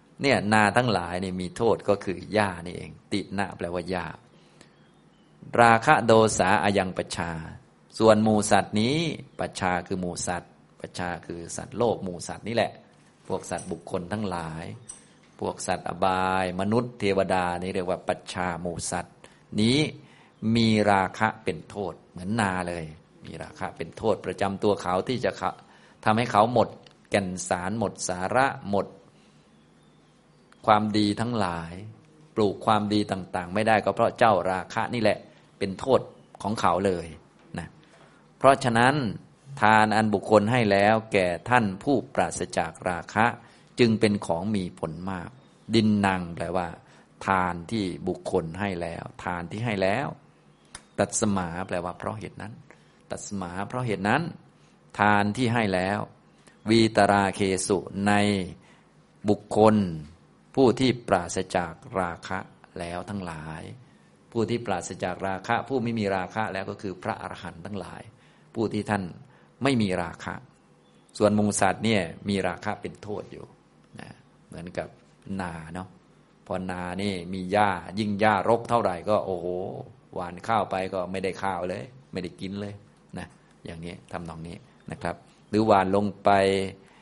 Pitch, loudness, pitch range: 100 Hz, -26 LUFS, 90-110 Hz